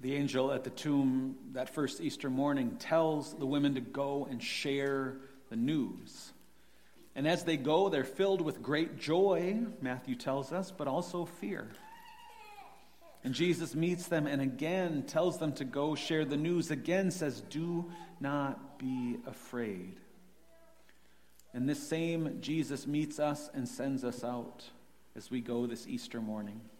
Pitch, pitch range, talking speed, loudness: 140 Hz, 130-165 Hz, 150 wpm, -35 LUFS